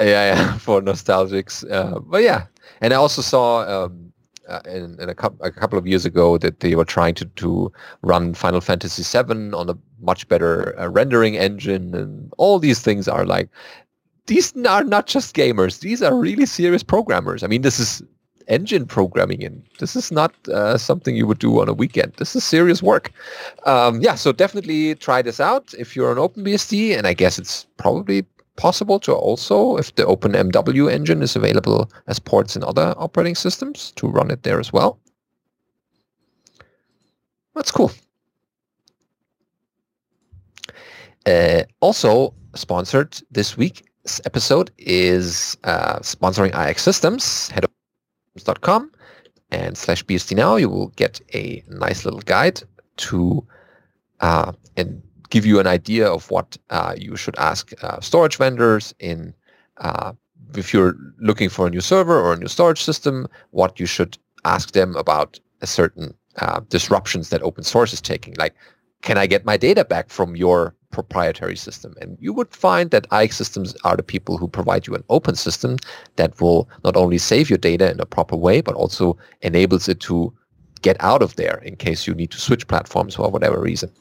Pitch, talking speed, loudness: 105 Hz, 175 wpm, -18 LUFS